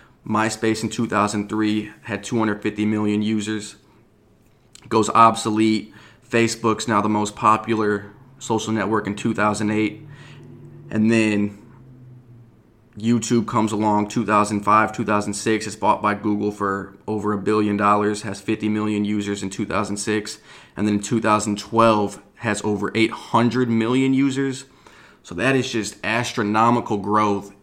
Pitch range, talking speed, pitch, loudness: 105-115 Hz, 120 wpm, 110 Hz, -21 LUFS